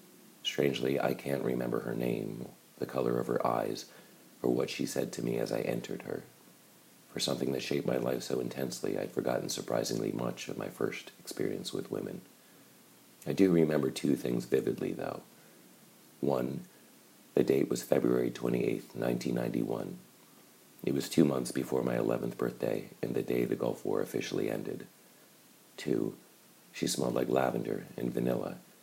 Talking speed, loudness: 160 wpm, -33 LUFS